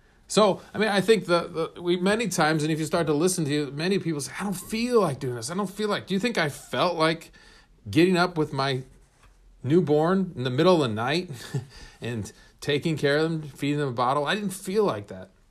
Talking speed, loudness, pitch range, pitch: 240 wpm, -25 LUFS, 145-185 Hz, 160 Hz